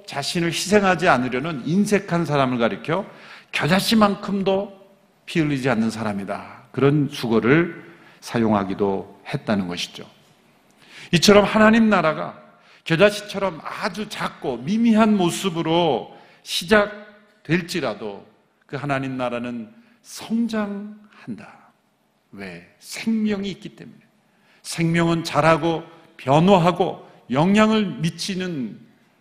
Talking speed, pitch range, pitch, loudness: 245 characters per minute, 145-210 Hz, 180 Hz, -20 LUFS